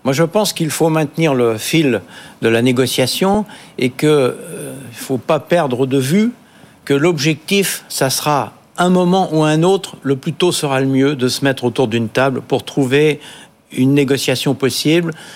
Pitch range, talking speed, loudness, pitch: 130-170 Hz, 180 wpm, -15 LUFS, 145 Hz